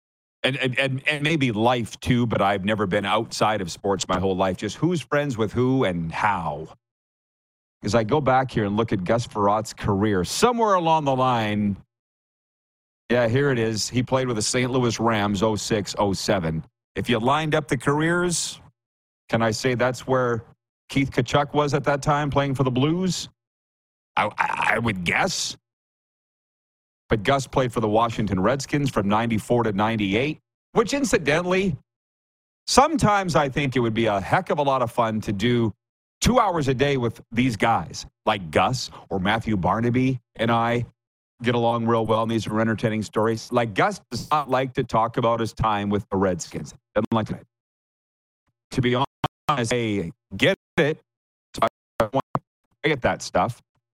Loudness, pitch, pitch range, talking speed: -23 LUFS, 120 Hz, 110-140 Hz, 170 wpm